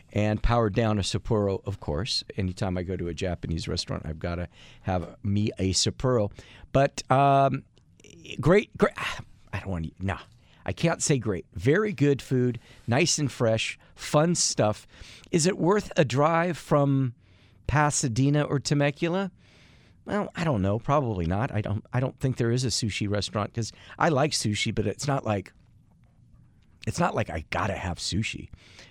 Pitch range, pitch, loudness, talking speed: 95-140 Hz, 110 Hz, -26 LUFS, 175 wpm